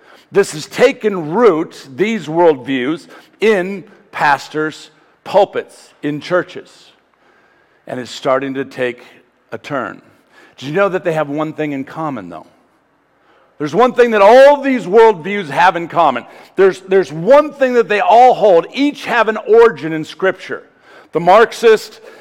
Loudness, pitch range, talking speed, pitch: -13 LUFS, 150-235 Hz, 150 wpm, 185 Hz